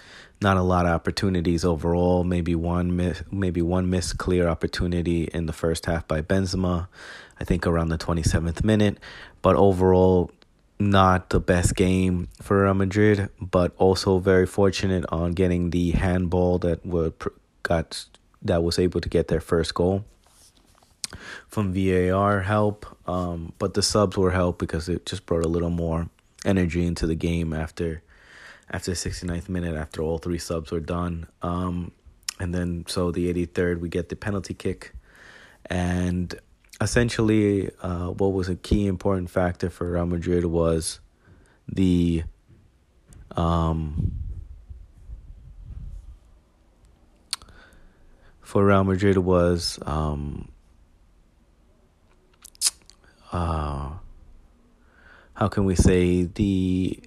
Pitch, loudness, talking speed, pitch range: 90 Hz, -24 LUFS, 130 wpm, 85-95 Hz